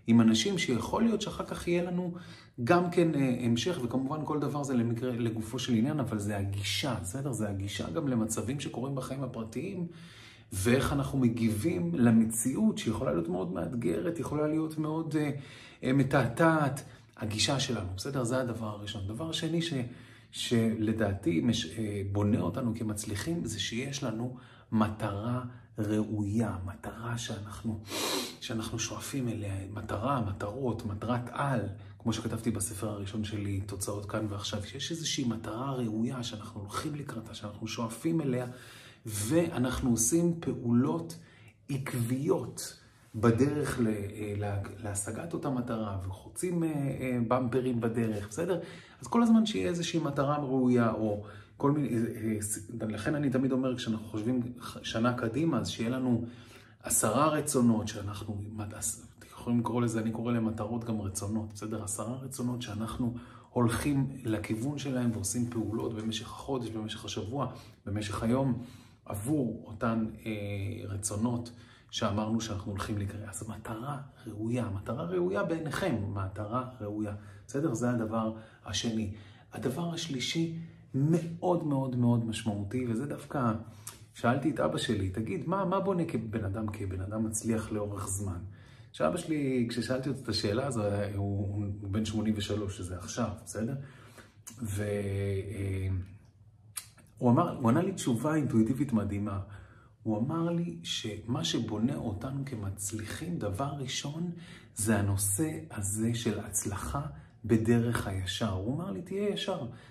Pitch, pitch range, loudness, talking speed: 115 Hz, 105-130 Hz, -32 LUFS, 125 wpm